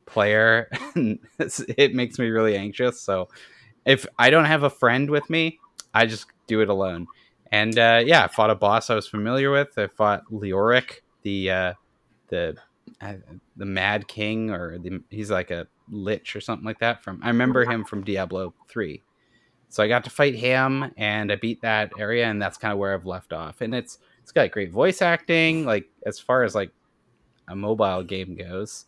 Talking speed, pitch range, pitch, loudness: 195 wpm, 100-125 Hz, 110 Hz, -22 LUFS